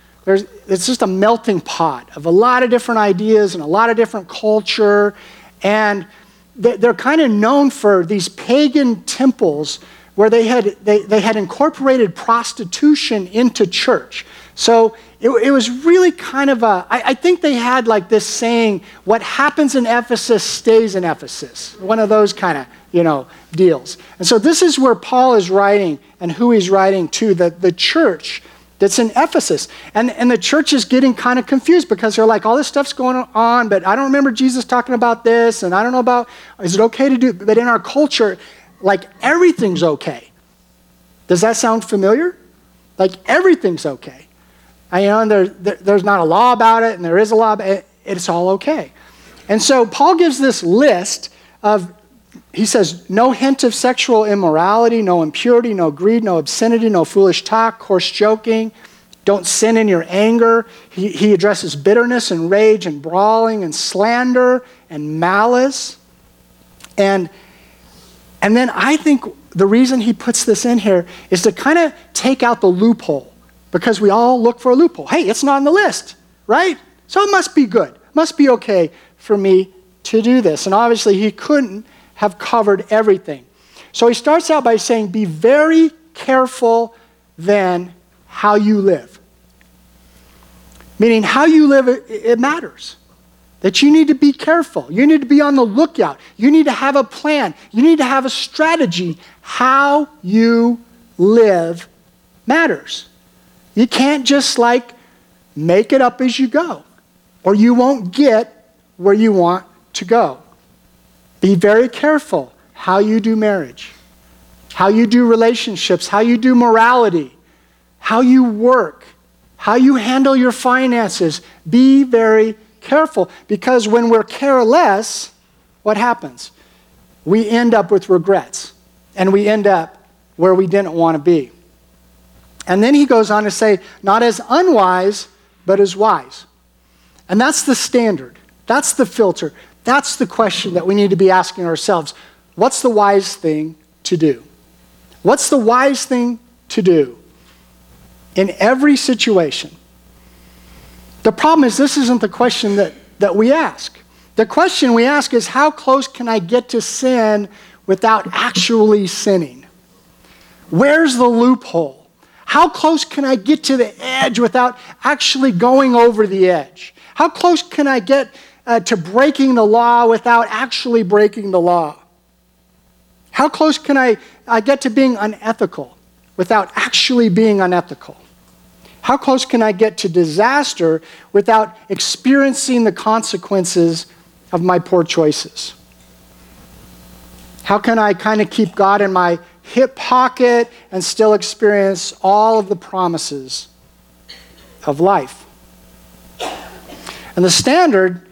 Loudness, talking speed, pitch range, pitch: -13 LUFS, 160 wpm, 180-250 Hz, 215 Hz